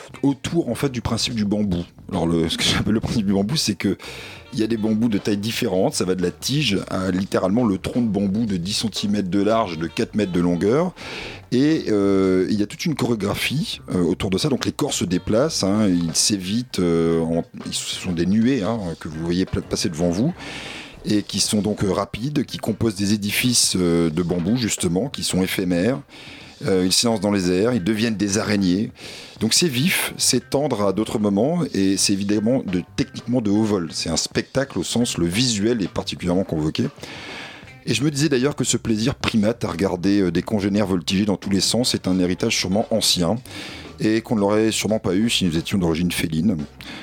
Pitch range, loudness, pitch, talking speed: 90-115 Hz, -21 LUFS, 105 Hz, 215 wpm